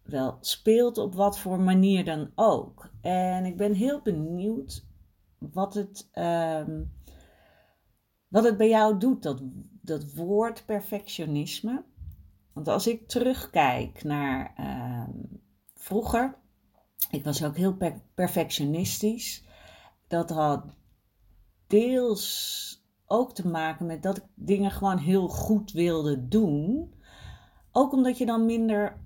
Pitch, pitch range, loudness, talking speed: 185 Hz, 150-215 Hz, -27 LUFS, 120 wpm